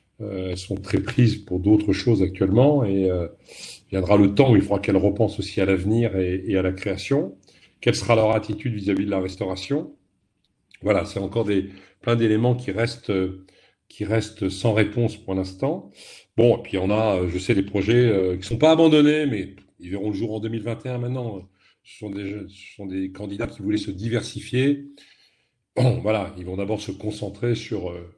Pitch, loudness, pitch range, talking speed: 100 Hz, -22 LUFS, 95-115 Hz, 190 wpm